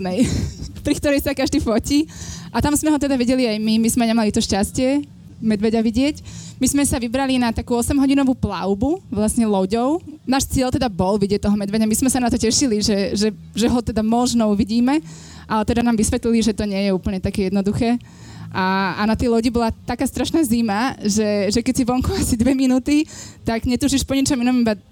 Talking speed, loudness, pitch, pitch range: 200 wpm, -19 LUFS, 235 Hz, 215-265 Hz